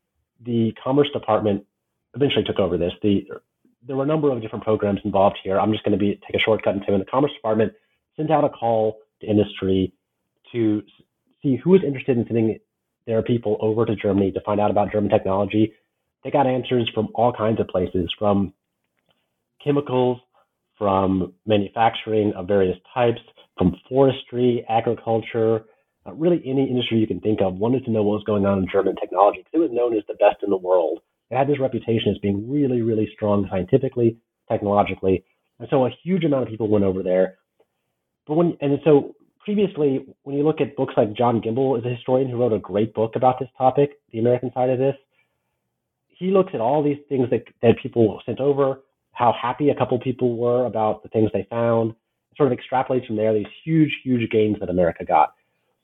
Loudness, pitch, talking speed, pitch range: -21 LUFS, 115 Hz, 200 wpm, 105-135 Hz